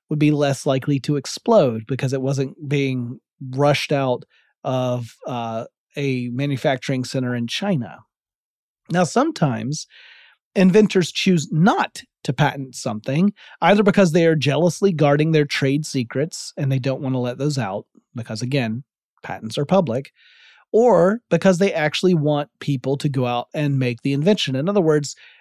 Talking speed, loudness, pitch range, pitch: 155 wpm, -20 LUFS, 130-170 Hz, 145 Hz